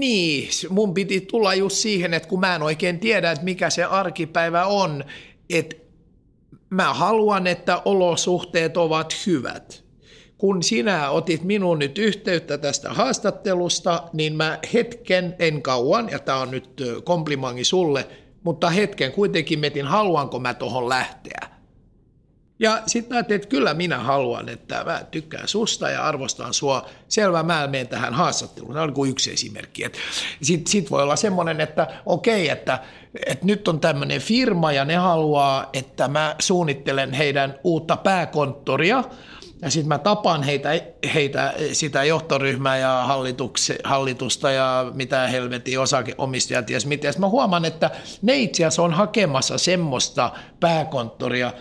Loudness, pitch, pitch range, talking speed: -21 LUFS, 165 Hz, 140-185 Hz, 140 wpm